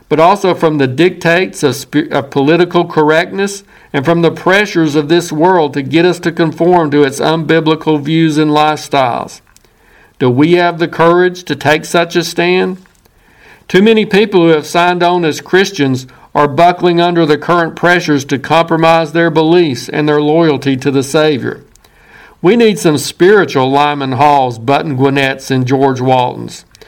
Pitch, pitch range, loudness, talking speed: 160 Hz, 145-175 Hz, -11 LUFS, 165 wpm